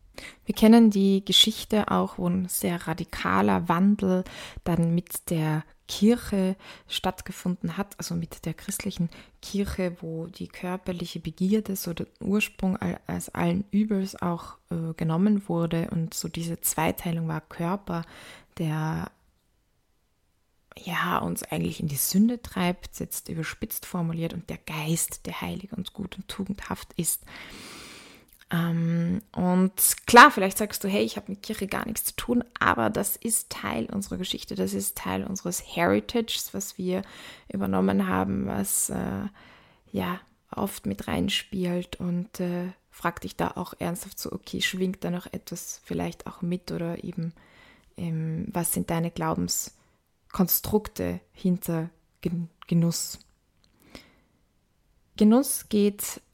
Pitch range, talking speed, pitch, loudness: 165-195 Hz, 135 wpm, 180 Hz, -26 LUFS